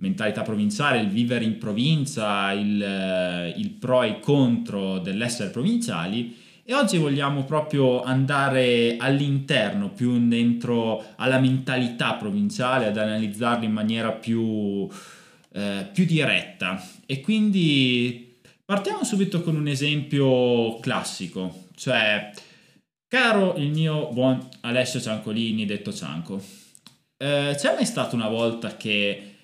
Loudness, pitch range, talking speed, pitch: -23 LUFS, 110-145 Hz, 115 wpm, 125 Hz